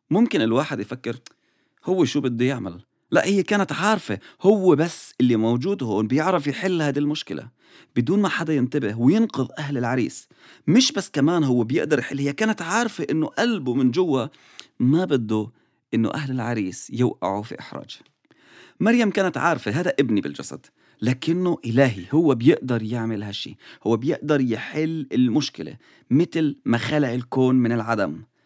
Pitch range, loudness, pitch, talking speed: 120-175 Hz, -22 LUFS, 140 Hz, 150 wpm